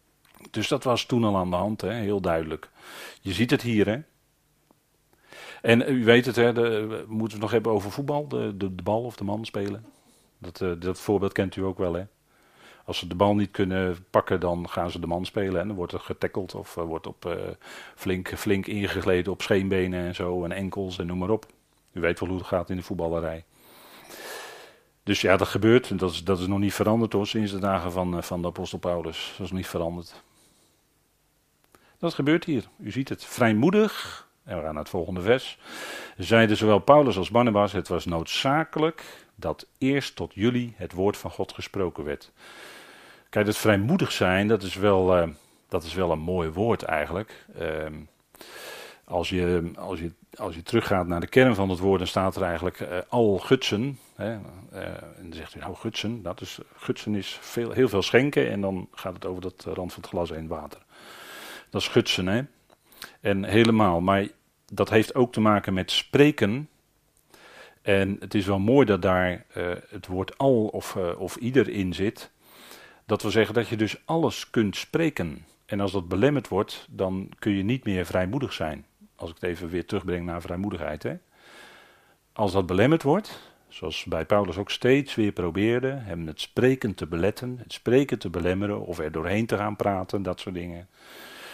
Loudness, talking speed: -26 LUFS, 200 wpm